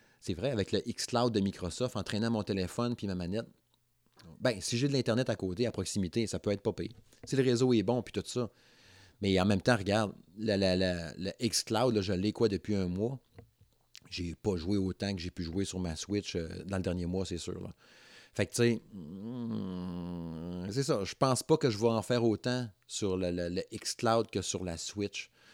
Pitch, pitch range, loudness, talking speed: 105 Hz, 95-120 Hz, -33 LUFS, 230 wpm